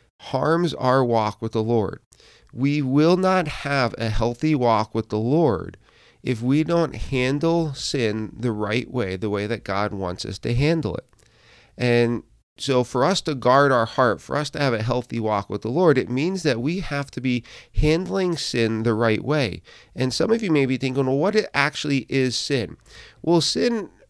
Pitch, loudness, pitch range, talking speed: 130 Hz, -22 LUFS, 115-150 Hz, 195 wpm